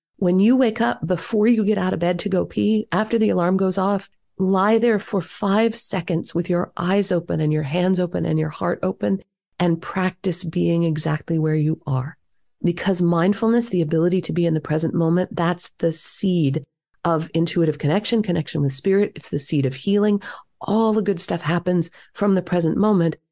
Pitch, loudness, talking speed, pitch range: 175 Hz, -21 LUFS, 195 wpm, 165-200 Hz